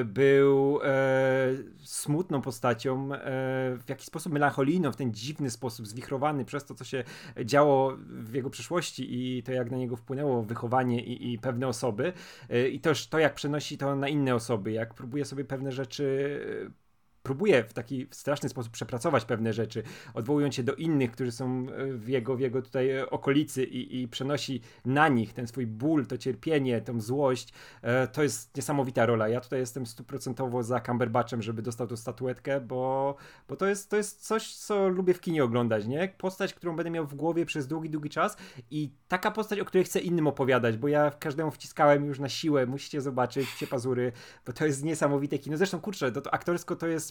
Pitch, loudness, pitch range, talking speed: 135 Hz, -29 LUFS, 125-150 Hz, 190 wpm